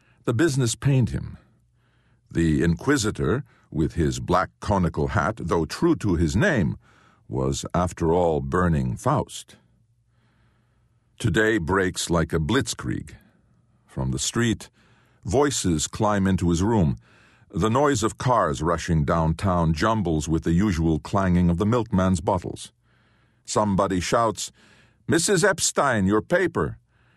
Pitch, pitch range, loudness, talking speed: 100 Hz, 85-115 Hz, -23 LUFS, 120 wpm